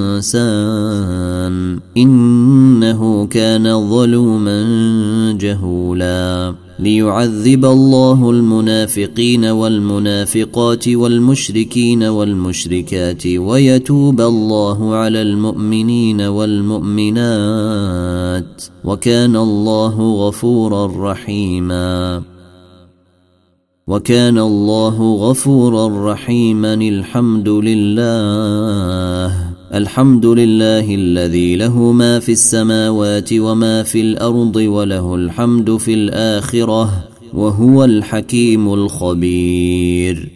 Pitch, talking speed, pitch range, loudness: 110 Hz, 60 wpm, 100-115 Hz, -13 LUFS